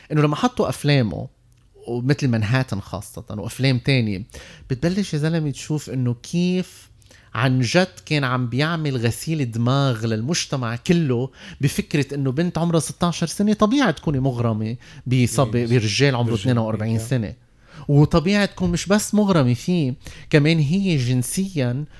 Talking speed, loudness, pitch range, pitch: 130 wpm, -21 LUFS, 120-165 Hz, 135 Hz